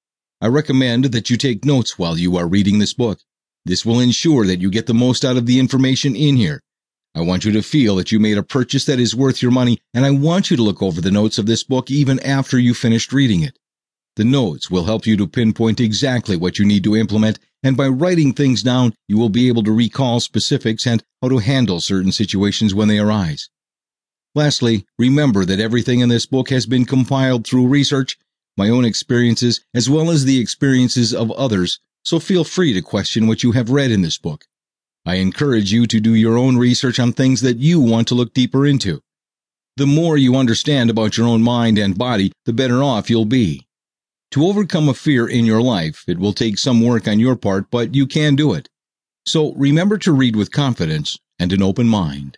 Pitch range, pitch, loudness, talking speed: 110-135 Hz, 120 Hz, -16 LUFS, 215 wpm